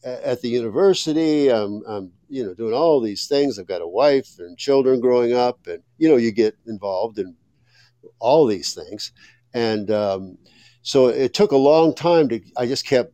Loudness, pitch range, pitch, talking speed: -19 LUFS, 110-140 Hz, 125 Hz, 185 wpm